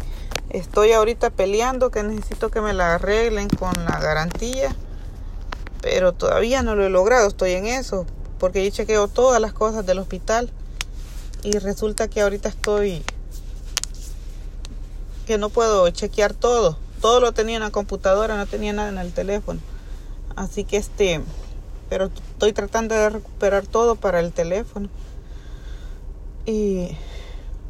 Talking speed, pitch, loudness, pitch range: 140 wpm, 205 Hz, -21 LUFS, 185-225 Hz